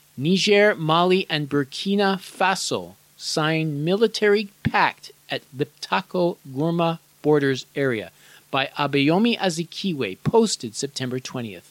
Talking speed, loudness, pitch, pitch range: 90 wpm, -22 LUFS, 160 Hz, 140-190 Hz